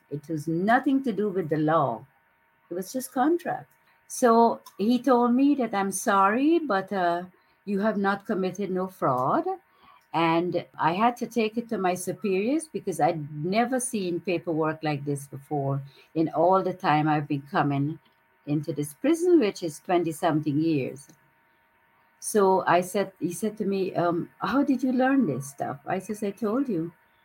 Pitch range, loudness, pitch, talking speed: 155-225 Hz, -26 LUFS, 185 Hz, 170 wpm